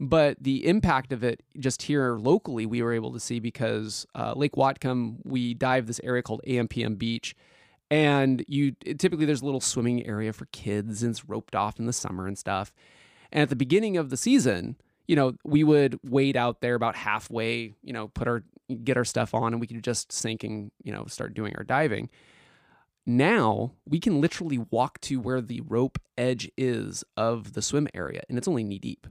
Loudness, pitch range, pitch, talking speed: -27 LUFS, 115-135 Hz, 125 Hz, 205 wpm